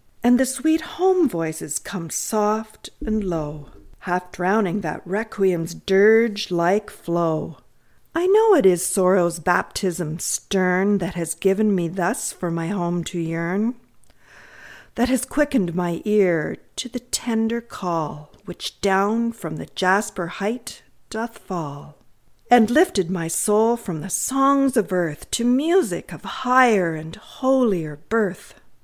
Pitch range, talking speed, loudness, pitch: 170-235 Hz, 135 wpm, -21 LUFS, 195 Hz